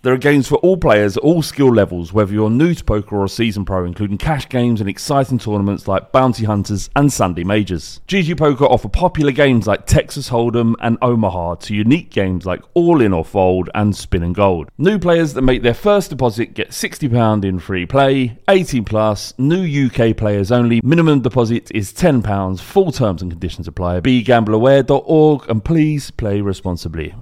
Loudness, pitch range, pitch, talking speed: -15 LUFS, 100-140 Hz, 115 Hz, 185 wpm